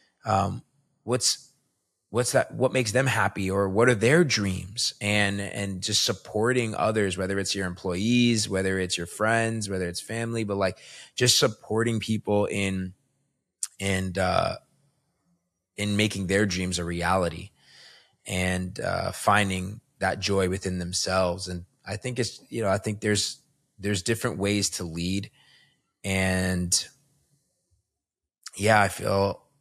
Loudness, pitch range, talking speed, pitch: -26 LUFS, 95-115 Hz, 140 wpm, 100 Hz